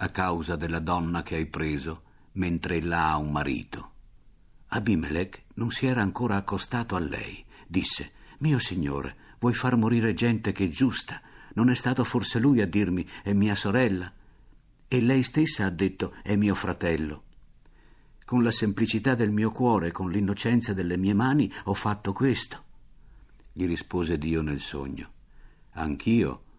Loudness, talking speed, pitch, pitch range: -27 LUFS, 155 wpm, 100 Hz, 85-115 Hz